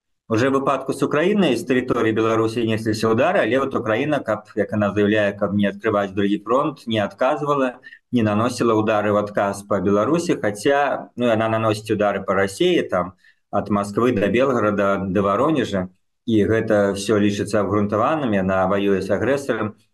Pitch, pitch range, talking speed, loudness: 105 Hz, 100-115 Hz, 155 wpm, -20 LUFS